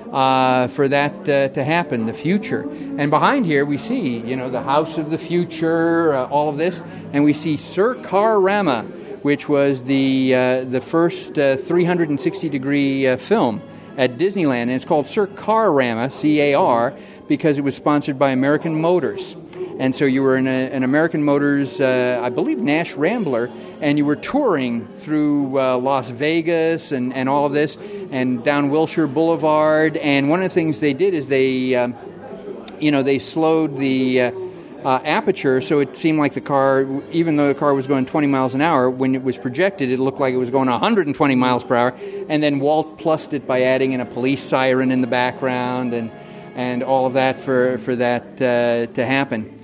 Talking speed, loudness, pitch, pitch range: 195 wpm, -18 LUFS, 140 Hz, 130-160 Hz